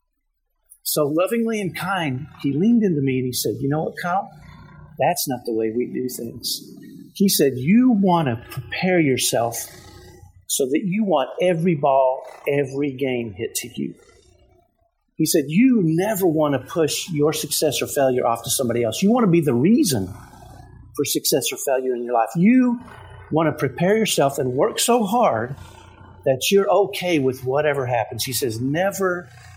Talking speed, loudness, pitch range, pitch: 175 wpm, -20 LUFS, 130-190 Hz, 150 Hz